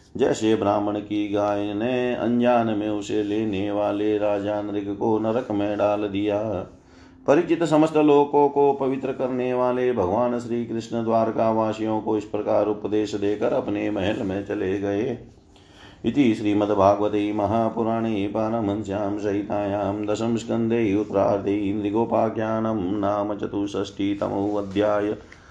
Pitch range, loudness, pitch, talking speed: 105-115 Hz, -23 LUFS, 105 Hz, 125 wpm